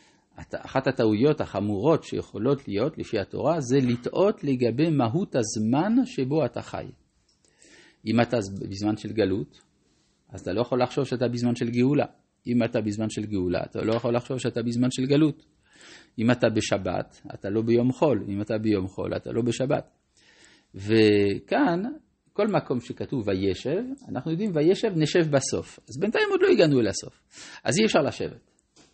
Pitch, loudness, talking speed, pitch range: 120 Hz, -25 LUFS, 160 wpm, 110-150 Hz